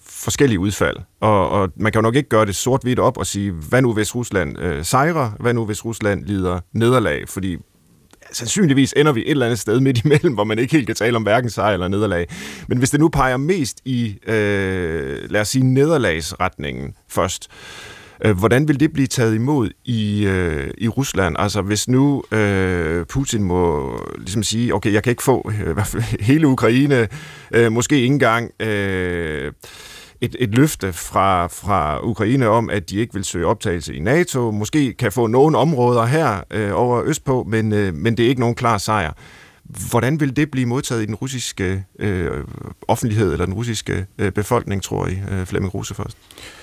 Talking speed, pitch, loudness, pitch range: 190 wpm, 115 Hz, -18 LUFS, 100-130 Hz